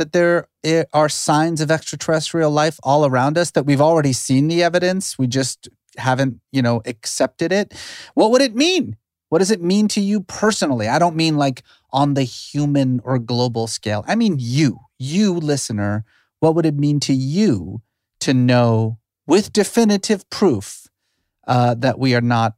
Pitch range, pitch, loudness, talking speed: 125-170 Hz, 145 Hz, -18 LUFS, 175 wpm